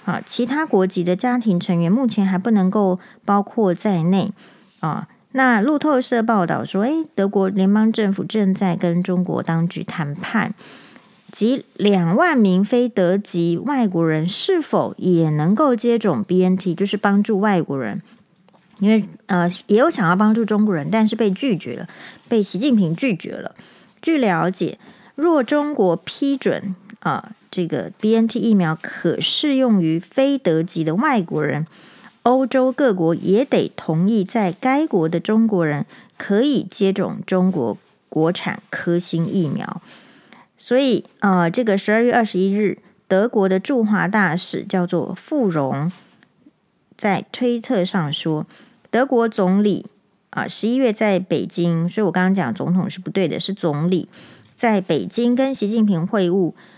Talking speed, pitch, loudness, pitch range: 230 characters per minute, 200 Hz, -19 LUFS, 180-230 Hz